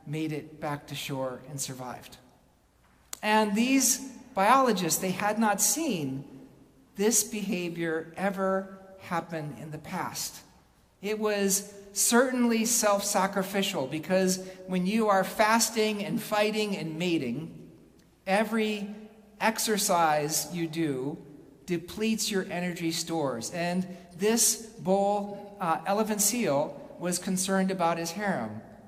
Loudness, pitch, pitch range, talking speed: -28 LUFS, 195 Hz, 165-215 Hz, 110 wpm